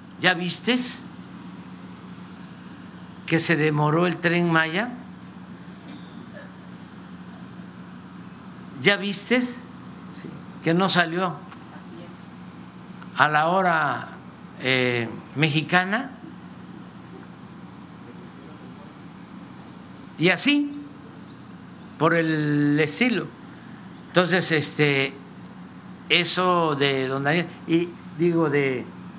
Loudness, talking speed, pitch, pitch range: -22 LUFS, 65 wpm, 170 Hz, 145-185 Hz